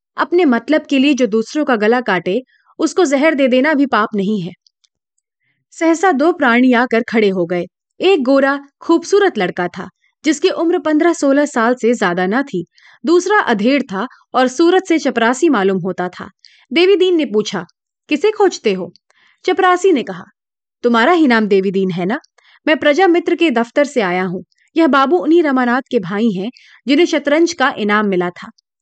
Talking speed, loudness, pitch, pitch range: 175 wpm, -14 LUFS, 270 Hz, 210-330 Hz